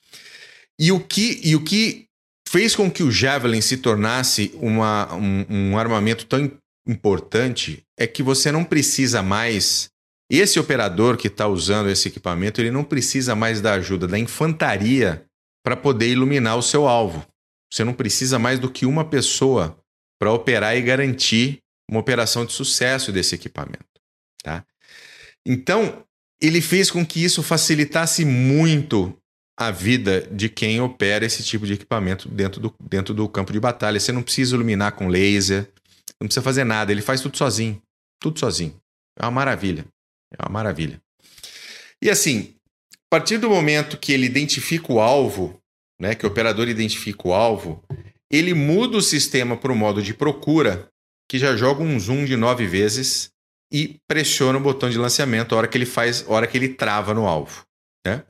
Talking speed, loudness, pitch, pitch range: 170 wpm, -20 LUFS, 120 Hz, 105-140 Hz